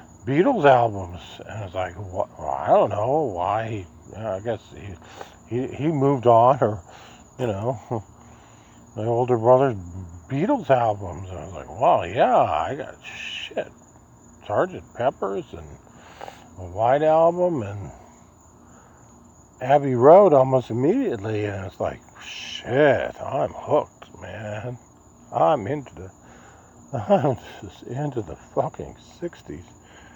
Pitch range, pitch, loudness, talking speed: 95-125 Hz, 110 Hz, -22 LUFS, 125 wpm